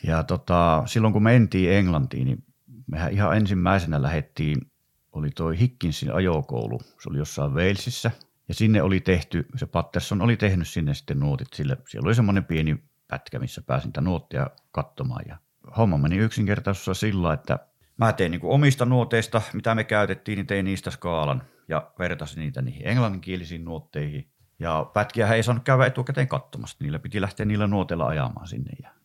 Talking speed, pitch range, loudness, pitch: 165 wpm, 85-115 Hz, -24 LUFS, 100 Hz